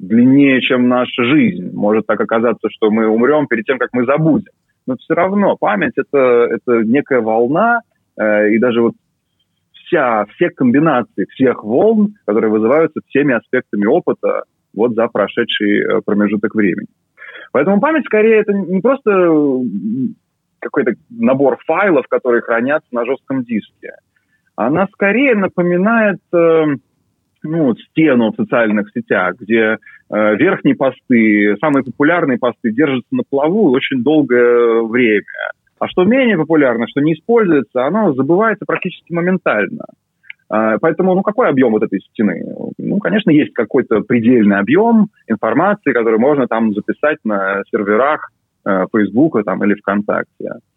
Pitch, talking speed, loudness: 140 Hz, 135 wpm, -14 LUFS